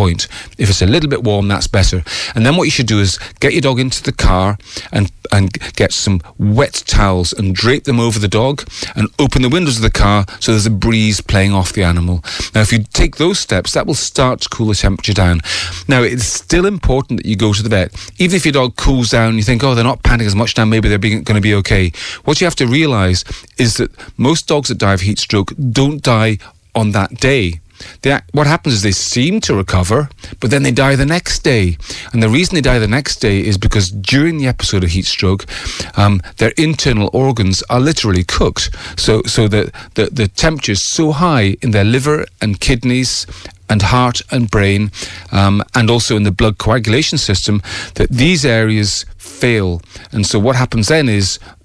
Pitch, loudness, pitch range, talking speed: 110 Hz, -13 LUFS, 100-130 Hz, 215 wpm